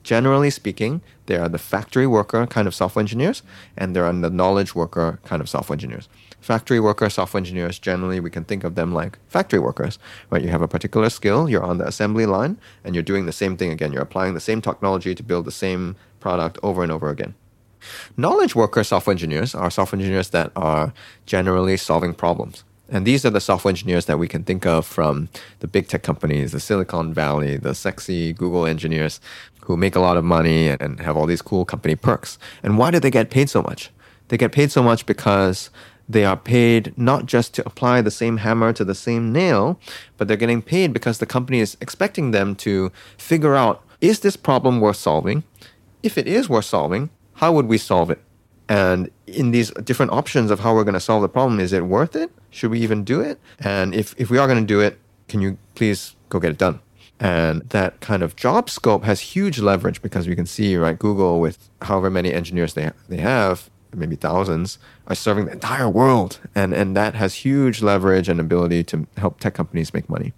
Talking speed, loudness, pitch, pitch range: 215 wpm, -20 LUFS, 100 Hz, 90-115 Hz